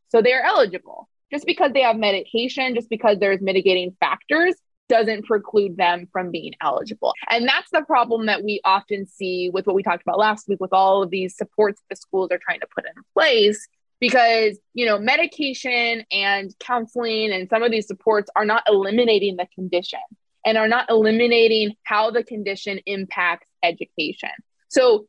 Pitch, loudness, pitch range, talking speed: 215 Hz, -20 LUFS, 195-235 Hz, 175 wpm